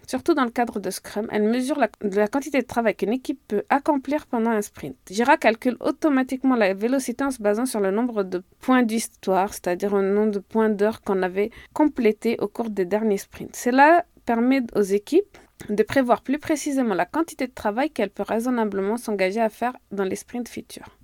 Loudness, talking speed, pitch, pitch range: -23 LUFS, 200 wpm, 230 Hz, 205-265 Hz